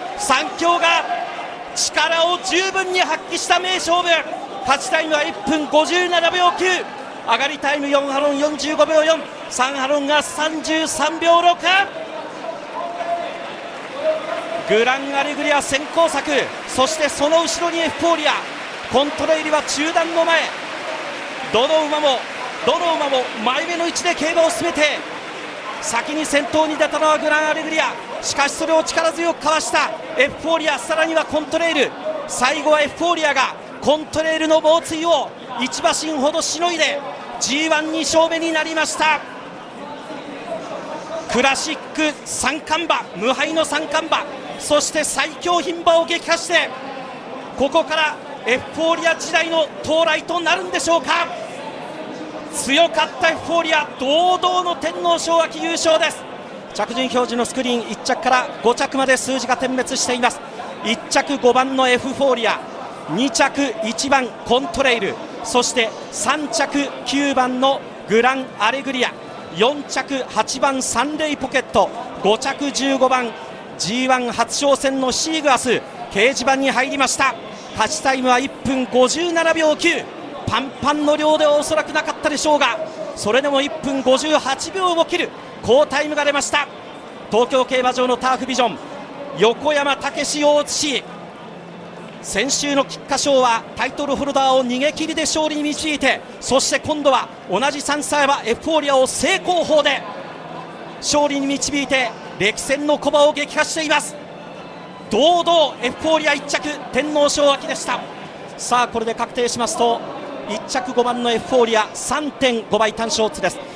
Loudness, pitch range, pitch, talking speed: -18 LUFS, 260-320 Hz, 295 Hz, 275 characters per minute